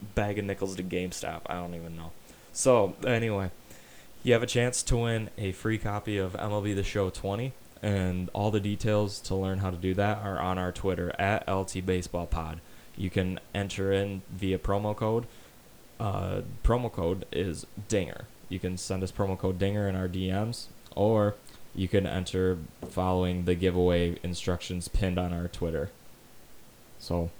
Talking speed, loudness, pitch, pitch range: 170 wpm, -30 LUFS, 95 Hz, 90-105 Hz